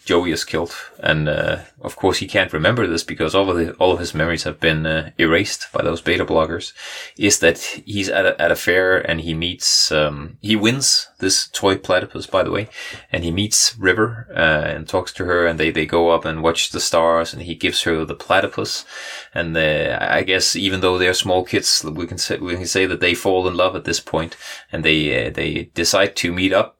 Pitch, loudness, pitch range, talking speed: 85 Hz, -18 LUFS, 80-95 Hz, 230 wpm